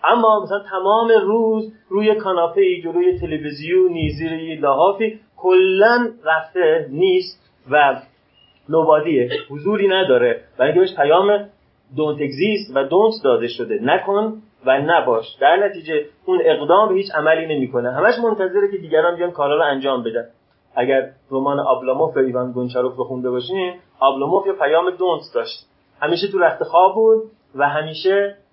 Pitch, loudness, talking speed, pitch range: 190 Hz, -18 LUFS, 145 wpm, 150-220 Hz